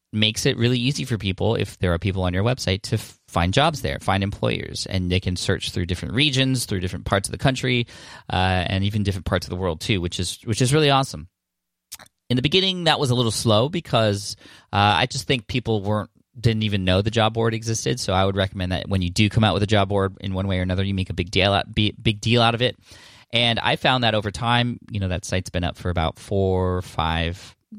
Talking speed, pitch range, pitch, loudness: 250 wpm, 95-120 Hz, 105 Hz, -22 LUFS